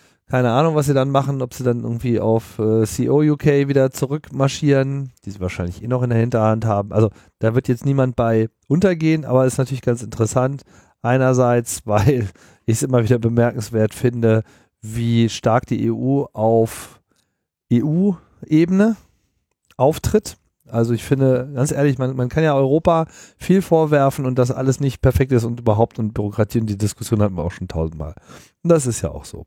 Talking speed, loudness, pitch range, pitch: 180 wpm, -19 LUFS, 110-140 Hz, 125 Hz